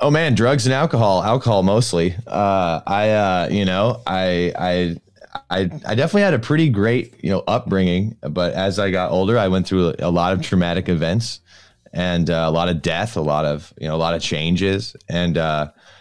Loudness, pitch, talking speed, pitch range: -19 LUFS, 95 Hz, 200 wpm, 85-110 Hz